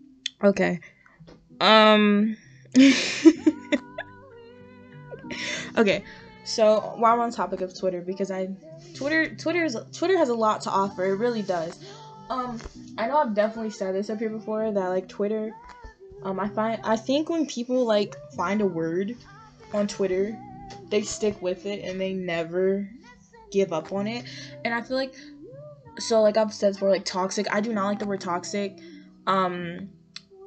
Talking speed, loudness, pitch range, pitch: 160 wpm, -25 LUFS, 185-230 Hz, 205 Hz